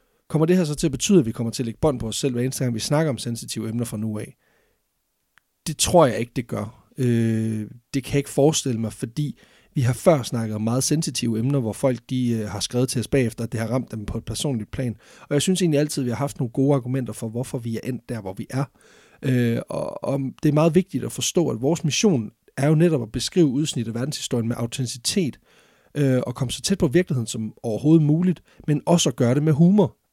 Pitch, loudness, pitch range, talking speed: 130 Hz, -23 LUFS, 115-150 Hz, 245 wpm